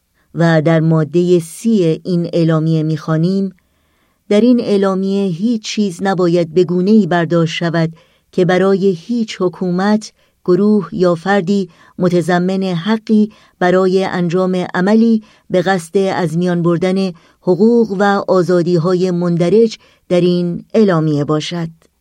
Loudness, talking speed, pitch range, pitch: -14 LUFS, 115 wpm, 170-200 Hz, 185 Hz